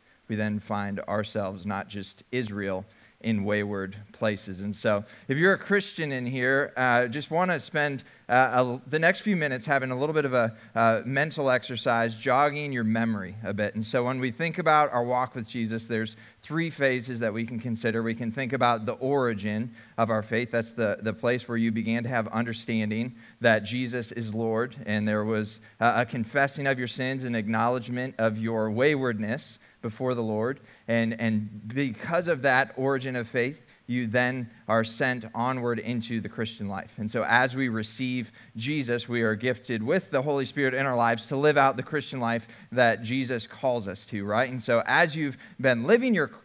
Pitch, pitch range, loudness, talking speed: 120 Hz, 110-130 Hz, -27 LUFS, 200 wpm